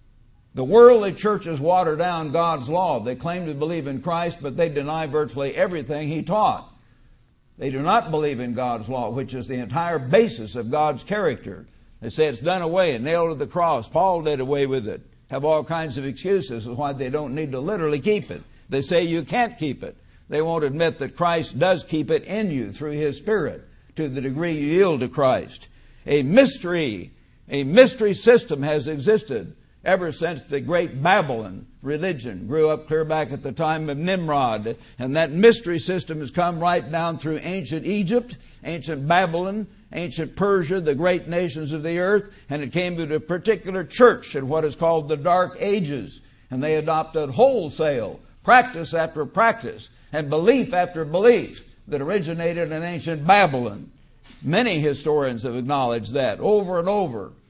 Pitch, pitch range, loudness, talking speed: 160 Hz, 145-180 Hz, -22 LUFS, 180 wpm